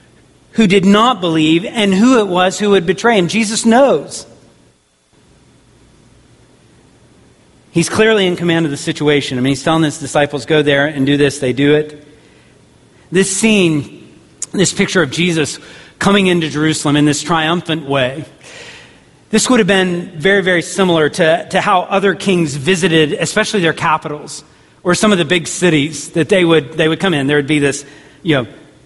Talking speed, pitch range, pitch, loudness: 175 wpm, 150-190 Hz, 165 Hz, -13 LUFS